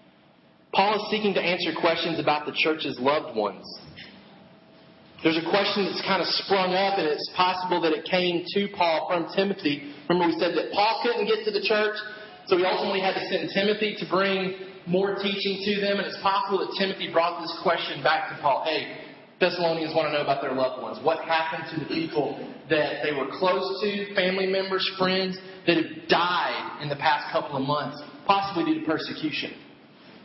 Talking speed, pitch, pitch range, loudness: 195 wpm, 185 Hz, 160-195 Hz, -25 LUFS